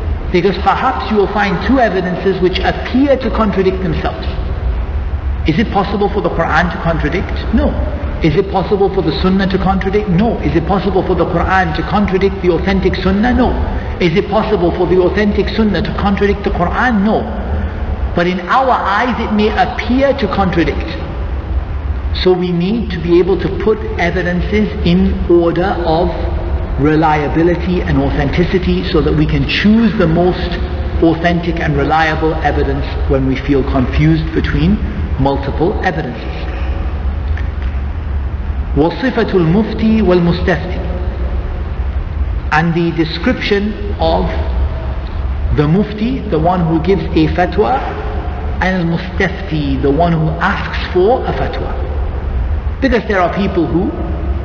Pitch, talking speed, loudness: 160 Hz, 140 wpm, -14 LUFS